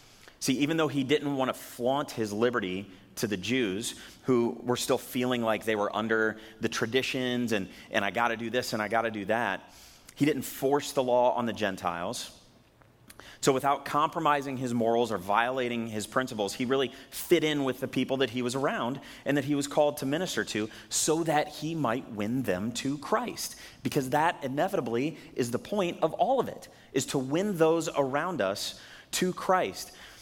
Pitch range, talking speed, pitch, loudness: 115-145 Hz, 195 wpm, 130 Hz, -29 LUFS